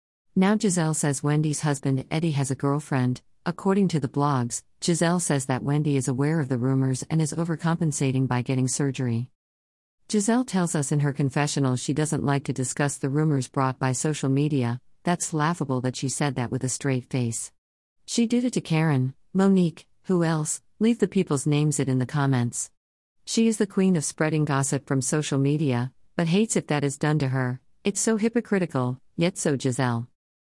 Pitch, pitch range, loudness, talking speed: 145 Hz, 130-165 Hz, -25 LUFS, 185 wpm